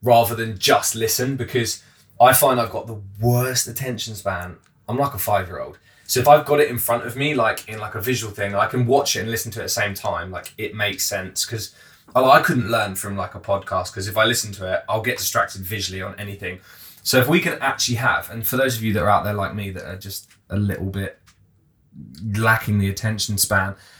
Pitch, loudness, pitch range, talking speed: 110 Hz, -20 LUFS, 100-120 Hz, 245 wpm